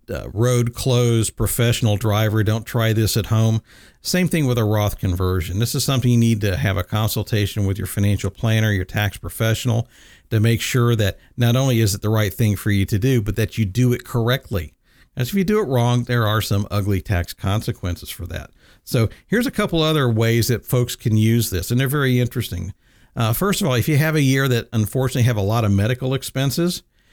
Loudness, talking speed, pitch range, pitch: -20 LUFS, 220 wpm, 105-125 Hz, 115 Hz